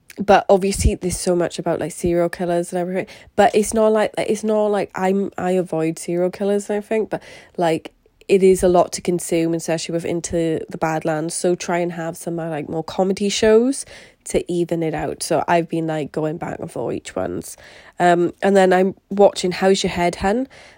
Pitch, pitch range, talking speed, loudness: 180 Hz, 165-195 Hz, 205 wpm, -19 LUFS